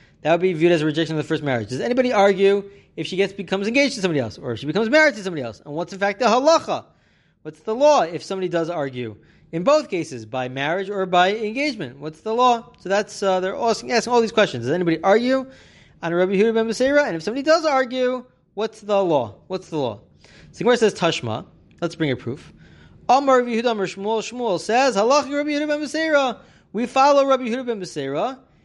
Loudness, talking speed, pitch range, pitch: -20 LUFS, 210 wpm, 165-245 Hz, 200 Hz